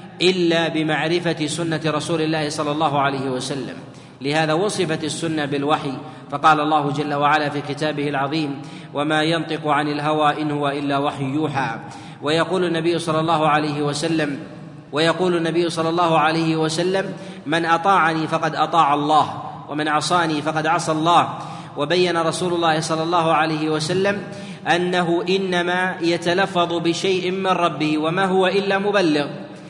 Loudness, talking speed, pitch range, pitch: -20 LUFS, 135 wpm, 150-170 Hz, 160 Hz